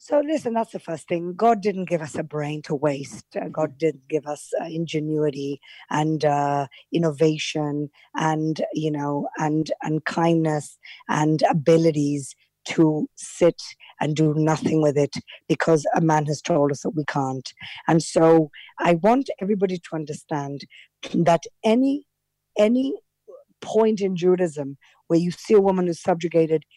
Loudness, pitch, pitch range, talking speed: -23 LUFS, 160 Hz, 150-180 Hz, 150 wpm